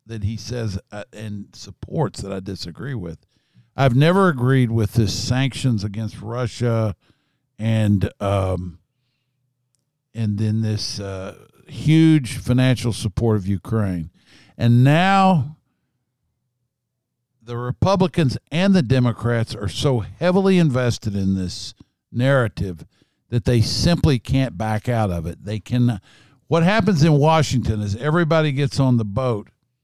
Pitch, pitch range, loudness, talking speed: 120 Hz, 105-135 Hz, -20 LUFS, 125 wpm